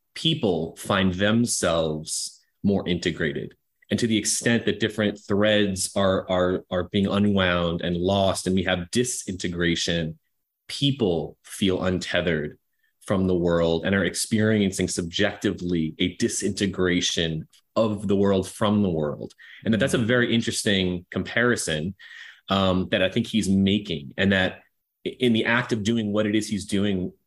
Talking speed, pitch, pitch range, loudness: 145 wpm, 95 Hz, 90-105 Hz, -24 LUFS